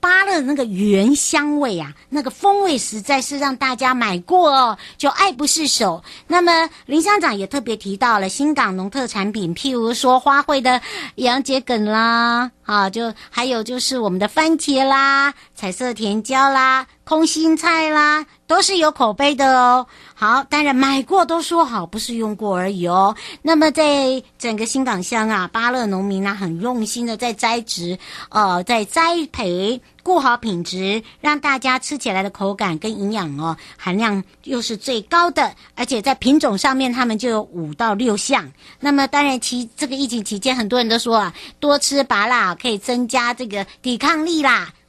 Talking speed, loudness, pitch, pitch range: 260 characters per minute, -17 LUFS, 250 Hz, 215-285 Hz